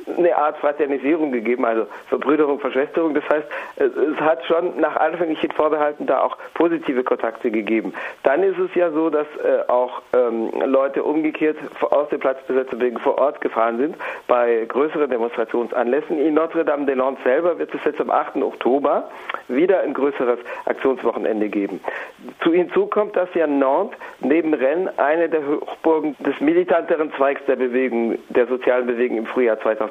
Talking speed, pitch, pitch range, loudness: 150 wpm, 150 Hz, 130-165 Hz, -20 LUFS